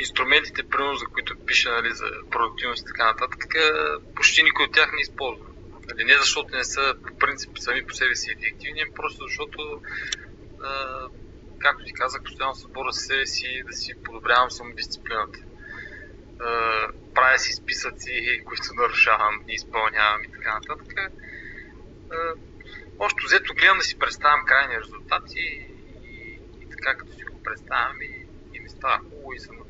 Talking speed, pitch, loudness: 155 wpm, 135 Hz, -23 LUFS